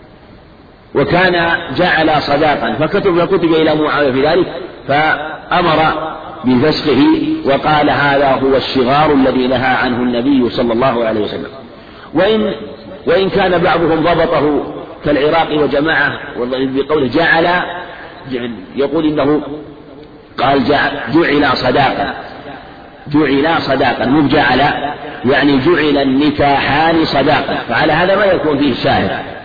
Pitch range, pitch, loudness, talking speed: 135-165 Hz, 145 Hz, -13 LUFS, 105 wpm